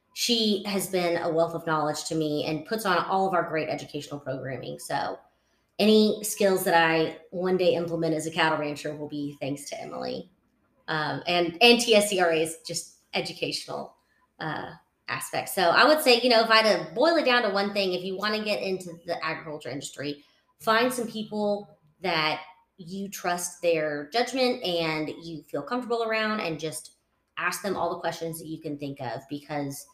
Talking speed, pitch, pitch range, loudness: 190 wpm, 170 Hz, 155-205 Hz, -26 LUFS